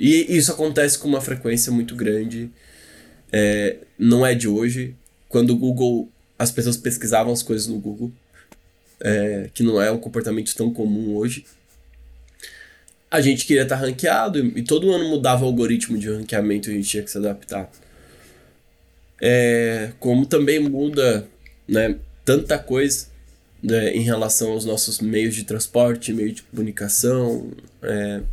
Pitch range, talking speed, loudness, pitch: 105-125 Hz, 150 wpm, -20 LUFS, 115 Hz